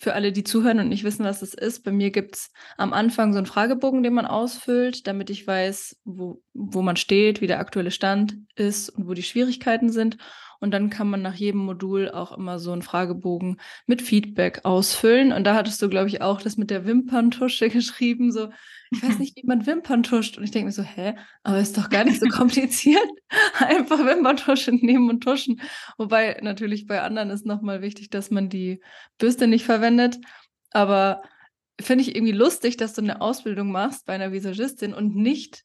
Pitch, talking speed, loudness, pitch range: 215 Hz, 200 wpm, -22 LUFS, 200-245 Hz